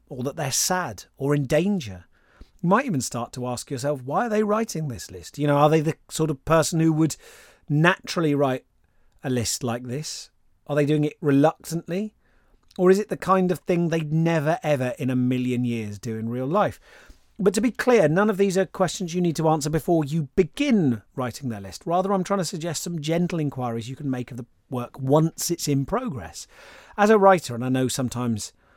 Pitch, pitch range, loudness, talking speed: 155 Hz, 130-180 Hz, -23 LUFS, 215 wpm